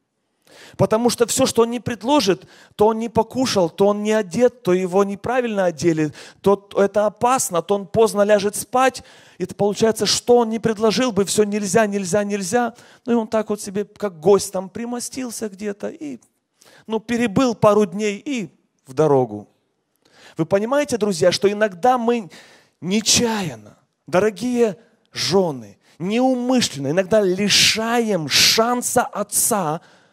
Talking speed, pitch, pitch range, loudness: 145 wpm, 210 Hz, 195-235 Hz, -19 LUFS